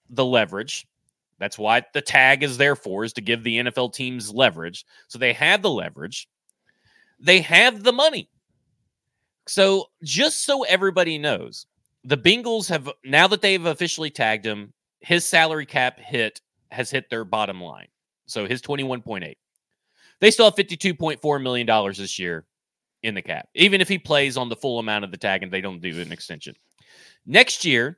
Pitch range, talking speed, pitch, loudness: 115-180 Hz, 175 wpm, 140 Hz, -20 LUFS